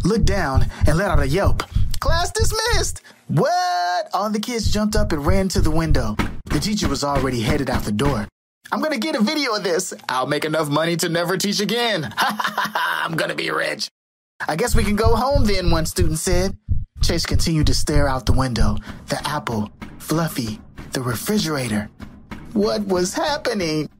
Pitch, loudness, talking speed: 155 Hz, -21 LUFS, 180 wpm